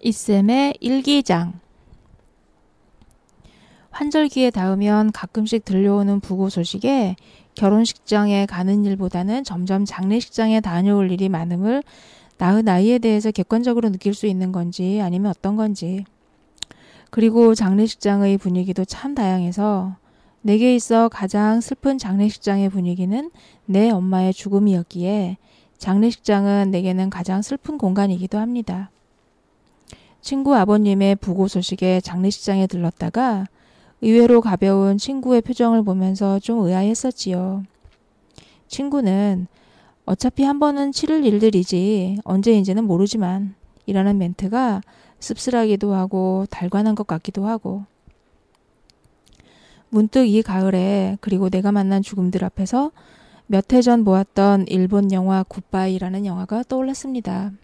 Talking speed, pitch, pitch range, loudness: 285 characters per minute, 200 Hz, 190-225 Hz, -19 LUFS